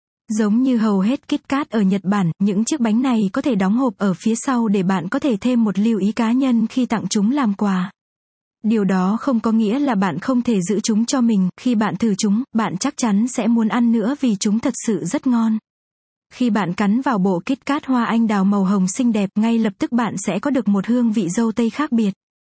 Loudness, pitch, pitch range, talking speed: -19 LUFS, 225 Hz, 205-245 Hz, 250 wpm